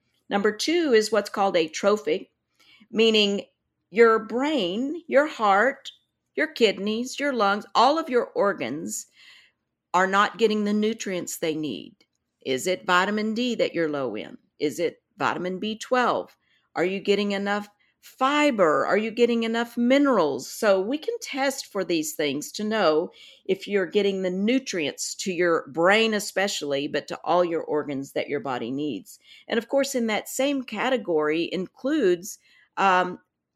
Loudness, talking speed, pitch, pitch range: -24 LUFS, 150 wpm, 205 Hz, 180-240 Hz